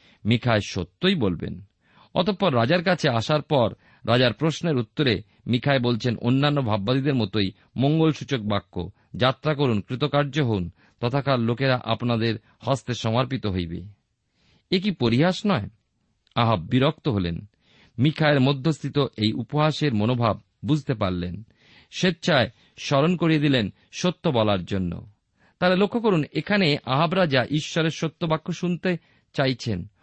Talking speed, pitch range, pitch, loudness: 120 wpm, 110-155 Hz, 125 Hz, -23 LUFS